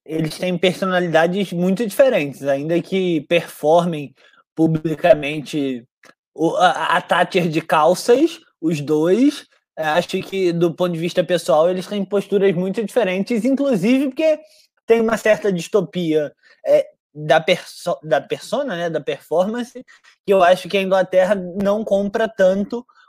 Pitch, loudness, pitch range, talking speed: 185 Hz, -18 LUFS, 170-225 Hz, 135 wpm